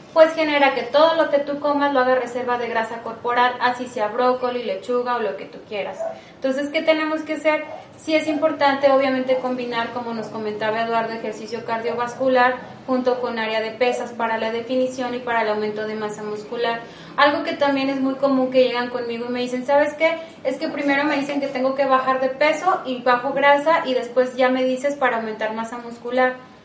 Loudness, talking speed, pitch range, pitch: -21 LUFS, 205 wpm, 235-285 Hz, 255 Hz